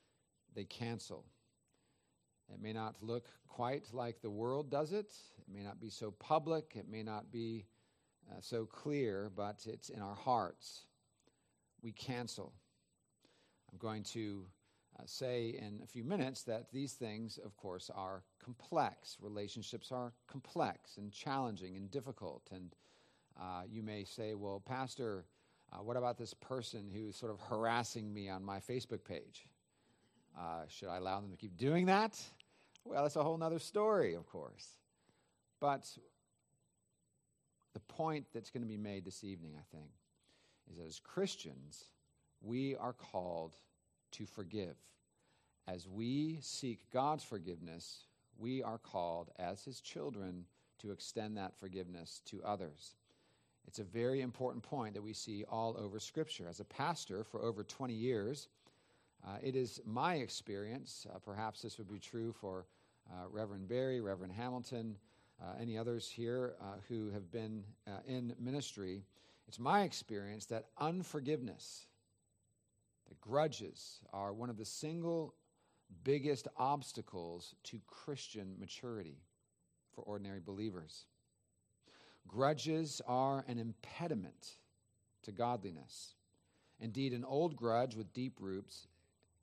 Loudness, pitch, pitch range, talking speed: -43 LUFS, 110 Hz, 100-125 Hz, 140 wpm